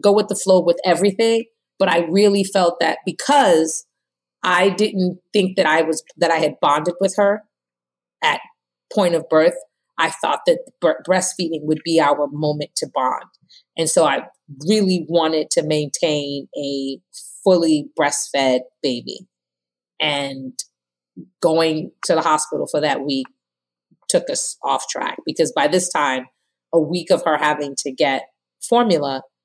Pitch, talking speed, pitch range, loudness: 165 Hz, 150 wpm, 145-190 Hz, -19 LUFS